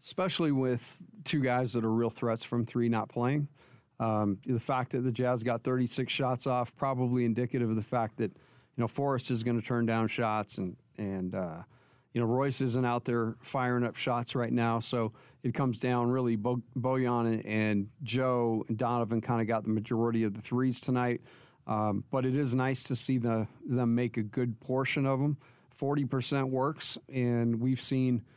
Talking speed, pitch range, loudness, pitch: 195 wpm, 115-130 Hz, -31 LUFS, 125 Hz